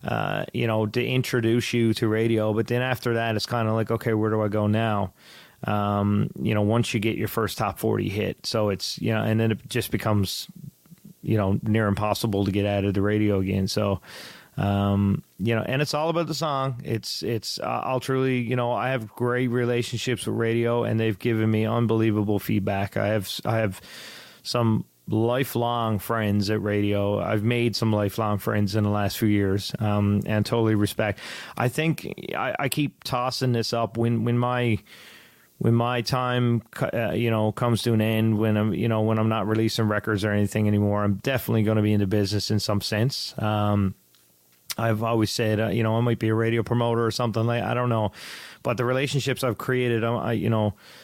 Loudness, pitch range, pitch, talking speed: -24 LUFS, 105-120 Hz, 110 Hz, 205 wpm